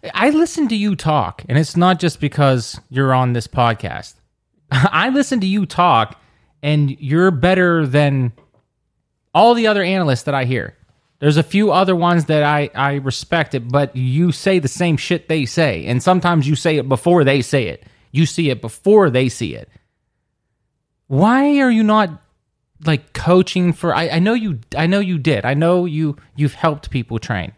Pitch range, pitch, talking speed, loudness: 130-180 Hz, 150 Hz, 185 wpm, -16 LUFS